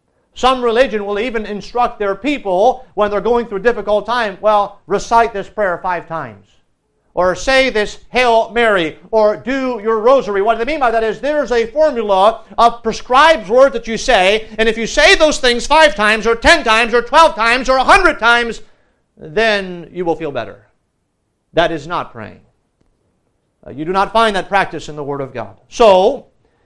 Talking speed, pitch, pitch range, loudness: 185 wpm, 225 Hz, 195-245 Hz, -13 LUFS